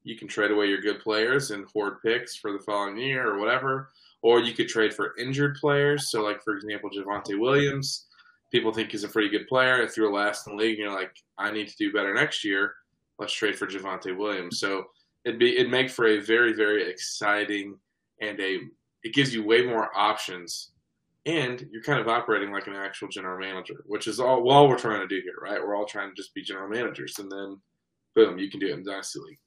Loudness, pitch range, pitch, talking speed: -26 LUFS, 100-130 Hz, 110 Hz, 230 wpm